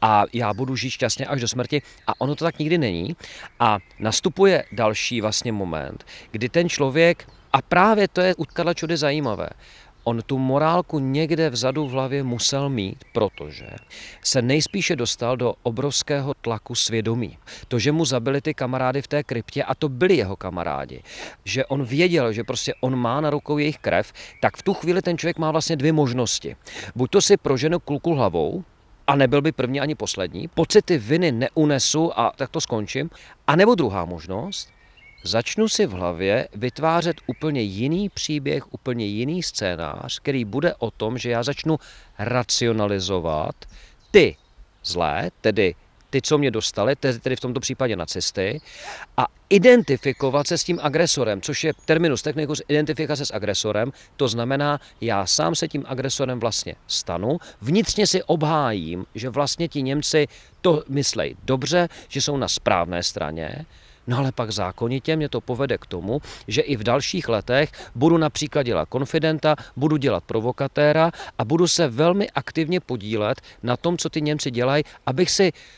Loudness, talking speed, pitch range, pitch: -22 LUFS, 165 wpm, 120-155 Hz, 135 Hz